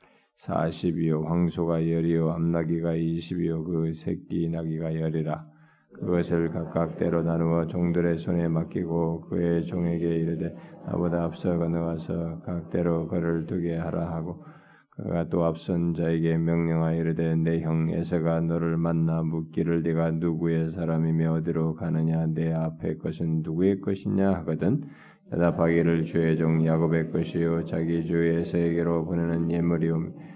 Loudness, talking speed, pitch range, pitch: -27 LUFS, 315 characters per minute, 80-85 Hz, 85 Hz